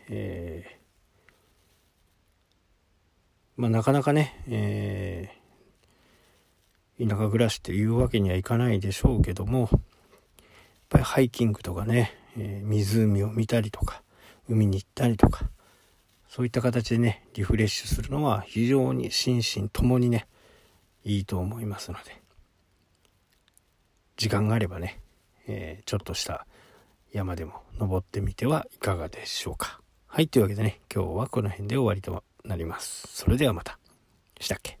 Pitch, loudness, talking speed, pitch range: 105 Hz, -27 LUFS, 285 characters per minute, 95-115 Hz